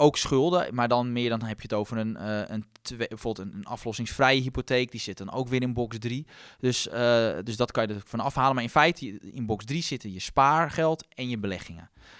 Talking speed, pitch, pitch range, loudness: 220 wpm, 120 Hz, 110-130 Hz, -27 LUFS